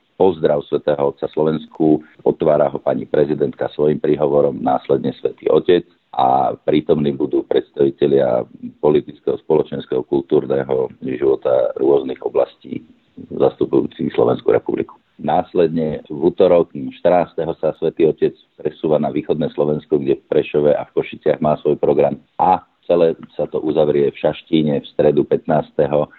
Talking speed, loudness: 130 wpm, -18 LUFS